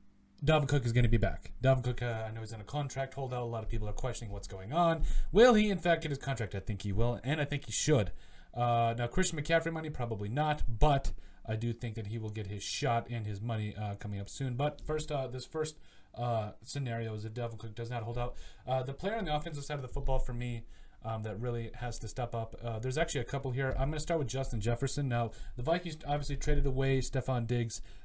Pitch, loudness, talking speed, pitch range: 120 Hz, -34 LUFS, 260 wpm, 115-145 Hz